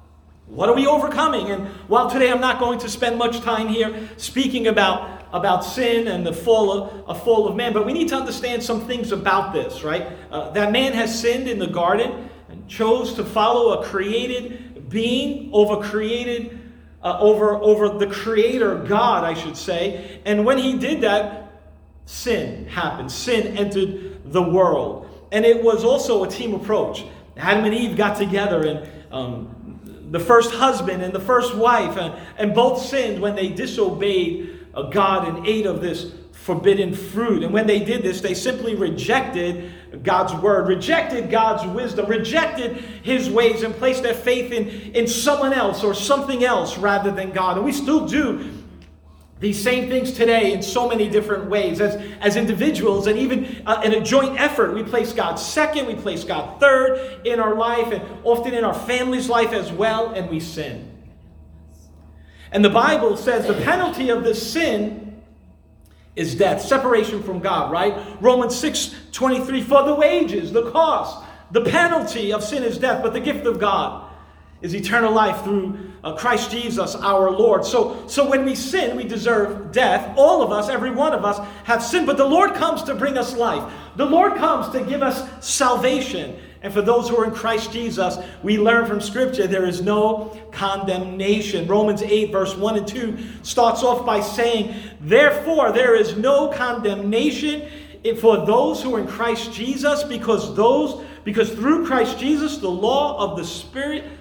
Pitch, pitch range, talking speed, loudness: 225 Hz, 200-250 Hz, 175 wpm, -20 LUFS